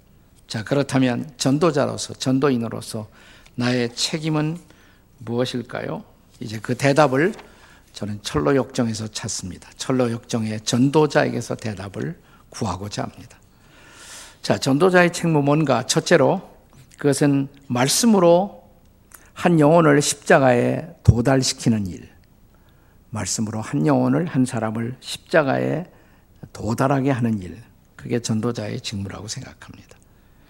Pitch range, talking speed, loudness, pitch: 110-145 Hz, 270 characters per minute, -20 LUFS, 125 Hz